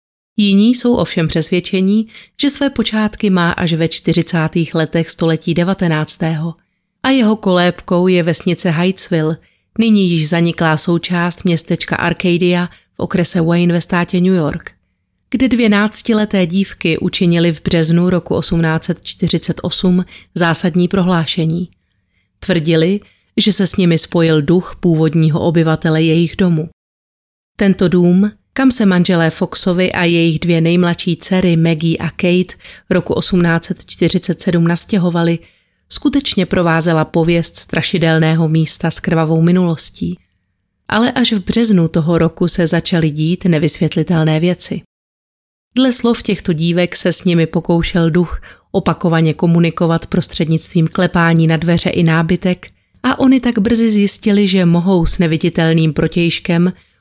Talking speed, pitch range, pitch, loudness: 125 wpm, 165-185 Hz, 175 Hz, -13 LUFS